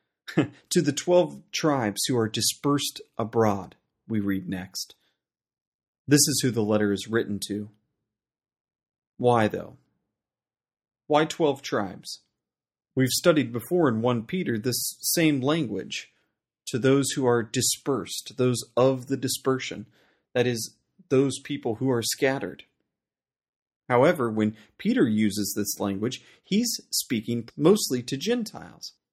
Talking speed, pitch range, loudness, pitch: 125 wpm, 110-145 Hz, -25 LUFS, 130 Hz